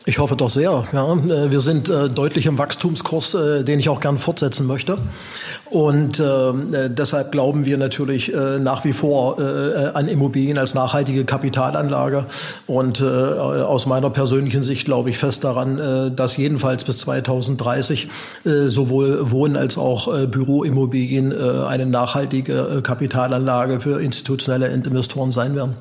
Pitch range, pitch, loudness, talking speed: 130-145 Hz, 135 Hz, -19 LUFS, 130 wpm